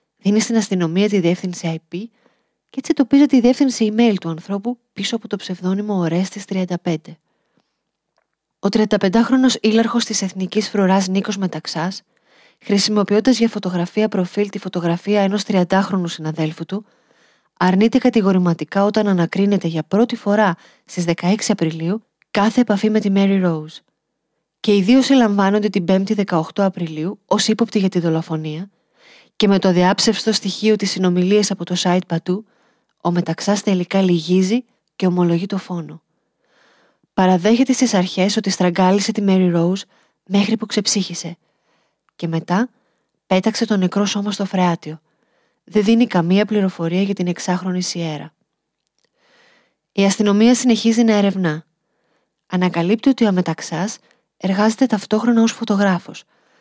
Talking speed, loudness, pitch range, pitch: 135 wpm, -18 LUFS, 180-220 Hz, 195 Hz